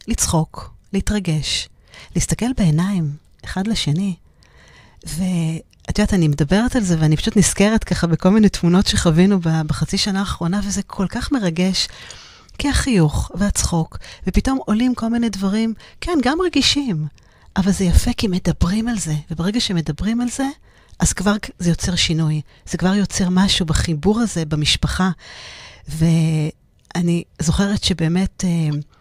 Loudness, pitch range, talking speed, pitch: -19 LUFS, 165-210 Hz, 130 wpm, 185 Hz